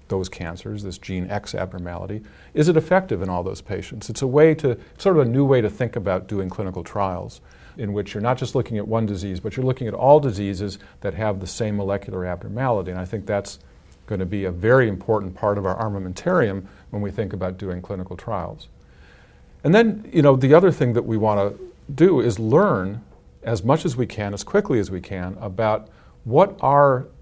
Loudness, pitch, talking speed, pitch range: -21 LUFS, 105 Hz, 215 wpm, 95-125 Hz